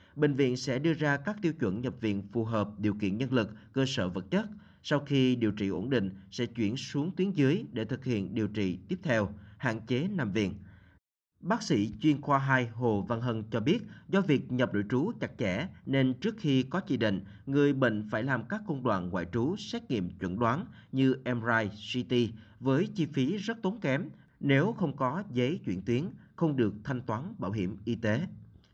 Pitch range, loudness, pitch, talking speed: 105-140 Hz, -31 LUFS, 125 Hz, 210 wpm